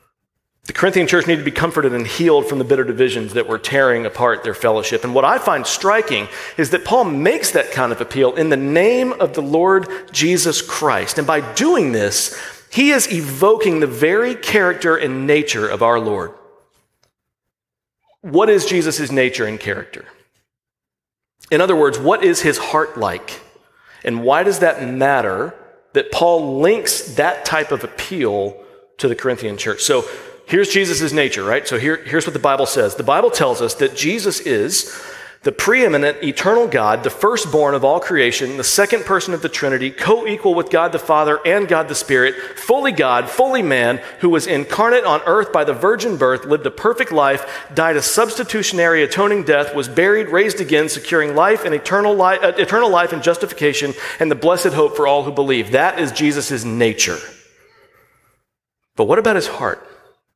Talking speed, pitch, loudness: 180 wpm, 175 Hz, -16 LUFS